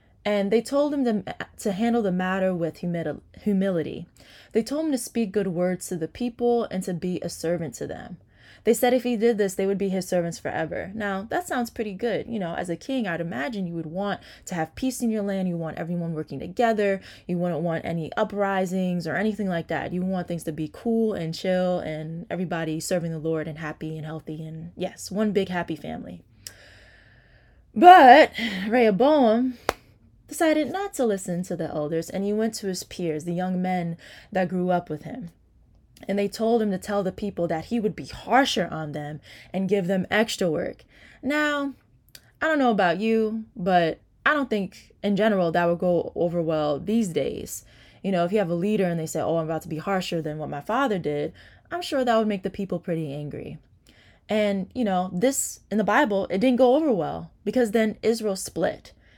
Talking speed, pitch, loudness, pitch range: 210 wpm, 190 Hz, -25 LUFS, 165-225 Hz